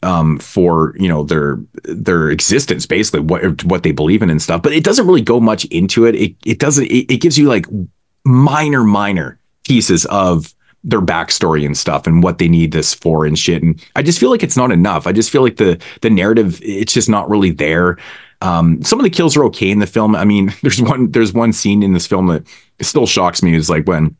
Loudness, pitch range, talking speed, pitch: -12 LUFS, 85-115 Hz, 235 wpm, 95 Hz